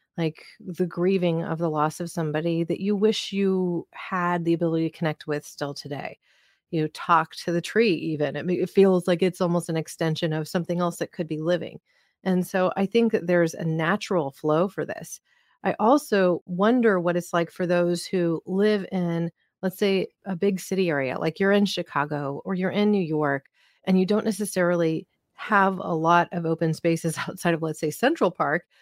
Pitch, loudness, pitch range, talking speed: 175 Hz, -25 LUFS, 165-190 Hz, 195 wpm